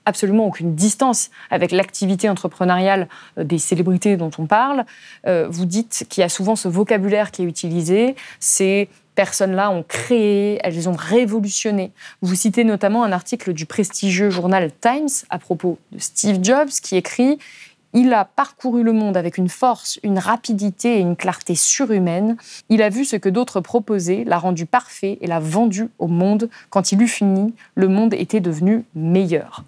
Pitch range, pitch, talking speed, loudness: 185-225 Hz, 200 Hz, 170 wpm, -18 LUFS